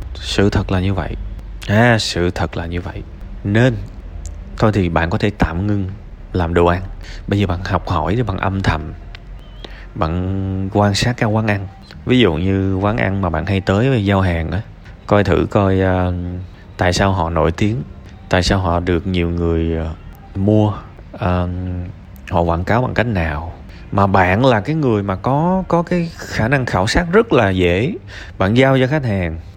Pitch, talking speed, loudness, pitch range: 95 Hz, 190 wpm, -17 LUFS, 90-105 Hz